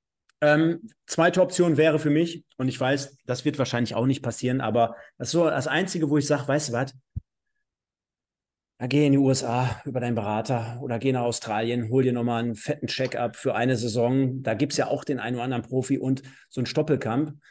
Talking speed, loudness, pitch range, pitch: 210 wpm, -25 LUFS, 120-150 Hz, 130 Hz